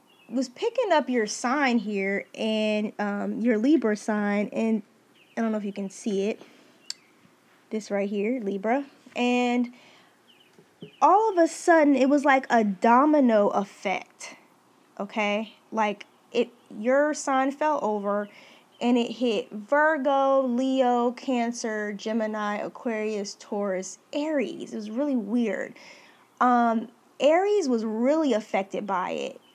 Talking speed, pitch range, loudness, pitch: 130 wpm, 210-270 Hz, -25 LUFS, 235 Hz